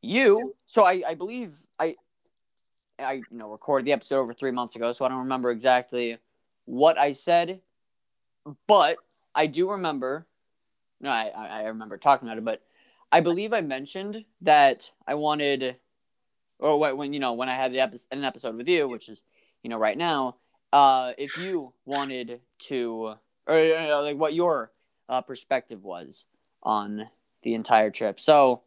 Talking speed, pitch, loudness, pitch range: 170 wpm, 130 Hz, -25 LUFS, 120-155 Hz